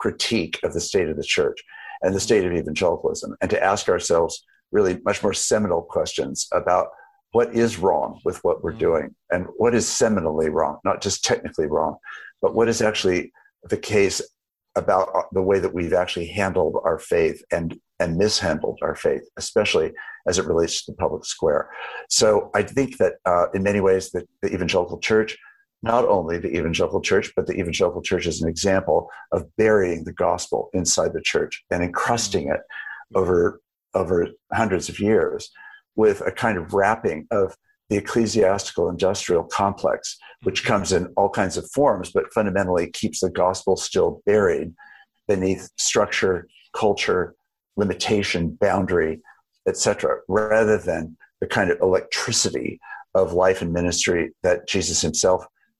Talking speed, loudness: 160 wpm, -22 LUFS